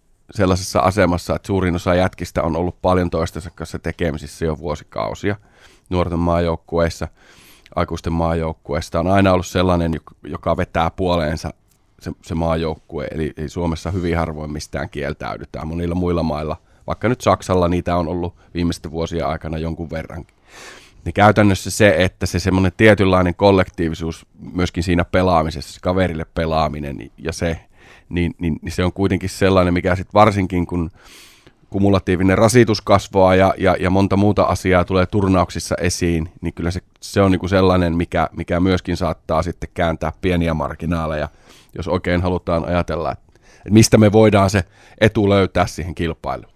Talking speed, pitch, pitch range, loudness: 150 wpm, 90 Hz, 80-95 Hz, -18 LUFS